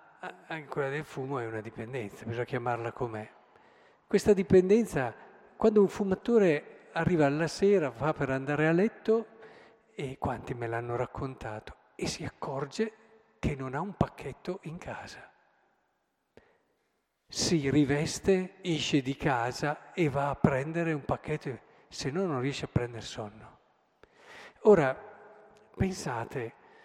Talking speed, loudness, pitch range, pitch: 125 wpm, -30 LUFS, 130-195 Hz, 150 Hz